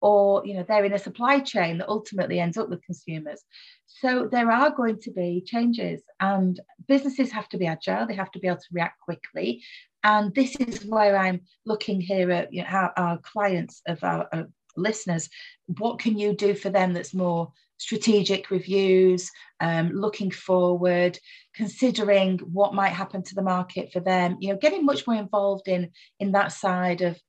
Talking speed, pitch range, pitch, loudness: 185 wpm, 180-215 Hz, 195 Hz, -25 LUFS